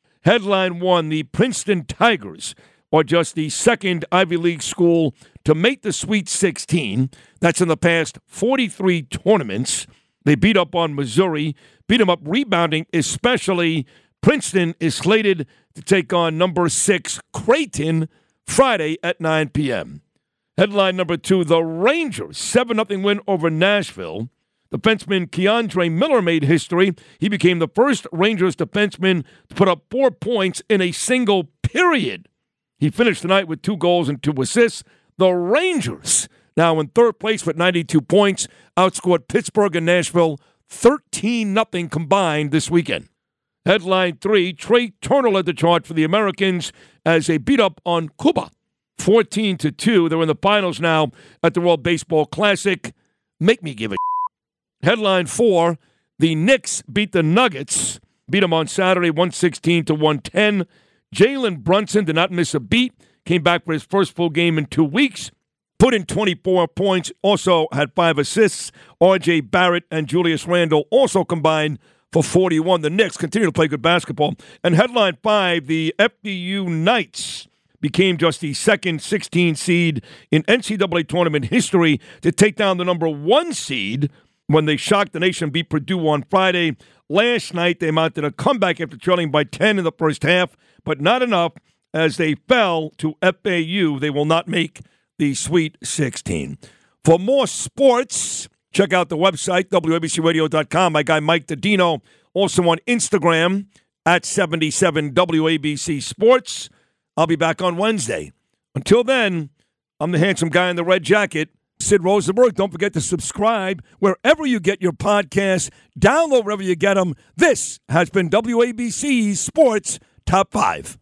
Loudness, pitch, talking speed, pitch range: -18 LUFS, 175 Hz, 155 wpm, 160-200 Hz